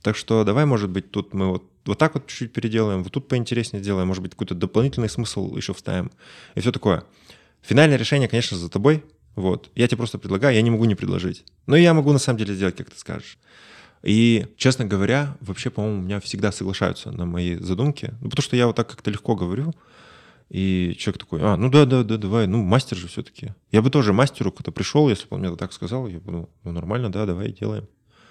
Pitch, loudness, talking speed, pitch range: 110 Hz, -22 LUFS, 225 wpm, 95-125 Hz